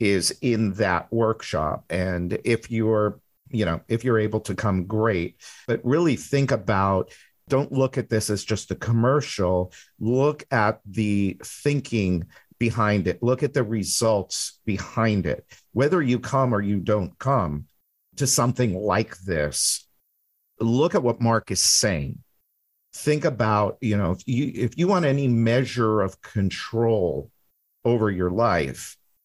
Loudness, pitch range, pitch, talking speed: -23 LUFS, 95-125 Hz, 110 Hz, 150 wpm